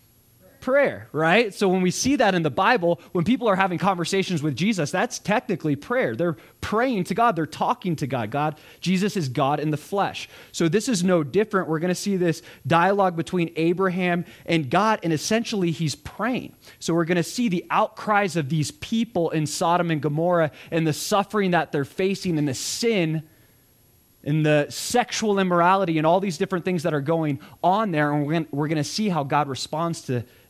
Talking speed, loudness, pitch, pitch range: 200 wpm, -23 LUFS, 170 Hz, 150-195 Hz